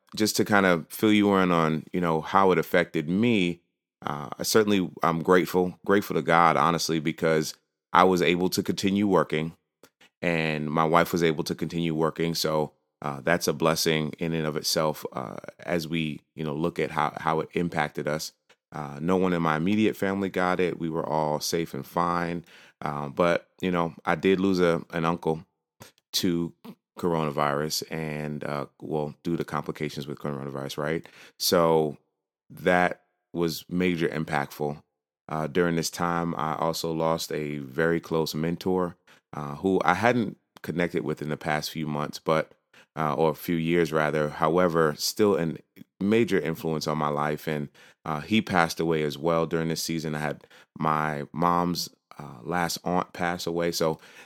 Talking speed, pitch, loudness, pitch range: 175 wpm, 80 Hz, -26 LUFS, 75-85 Hz